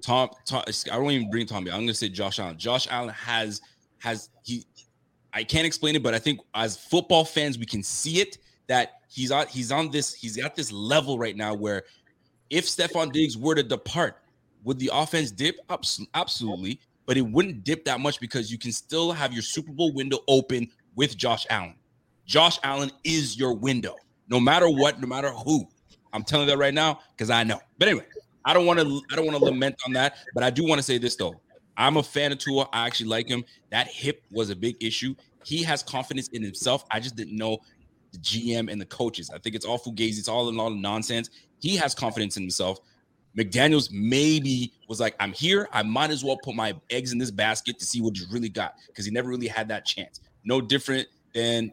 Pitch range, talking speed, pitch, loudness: 115-145 Hz, 225 wpm, 125 Hz, -26 LUFS